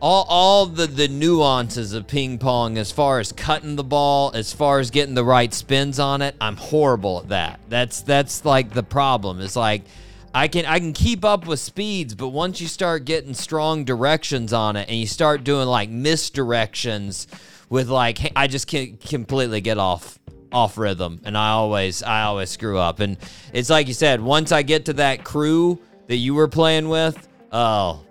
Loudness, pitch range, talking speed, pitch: -20 LUFS, 115-155 Hz, 195 wpm, 135 Hz